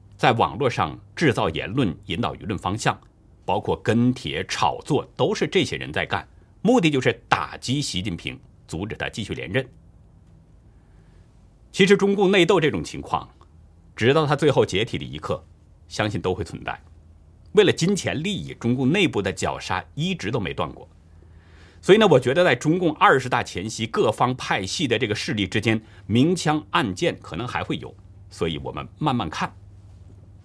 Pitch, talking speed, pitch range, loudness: 100 Hz, 255 characters per minute, 85-135 Hz, -22 LUFS